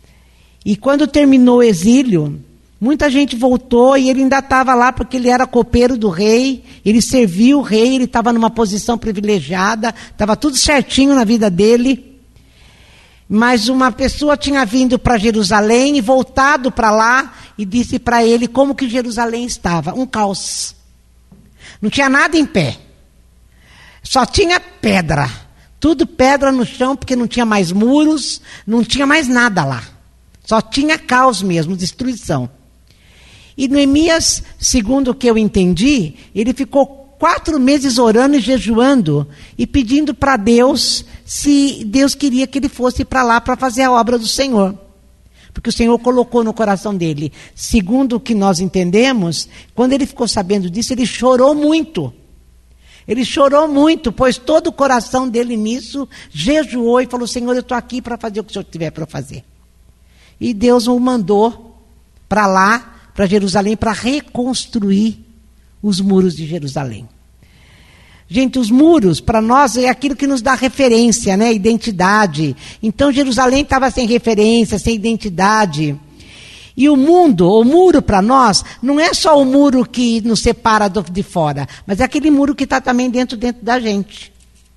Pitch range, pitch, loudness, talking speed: 205-265 Hz, 240 Hz, -13 LUFS, 155 wpm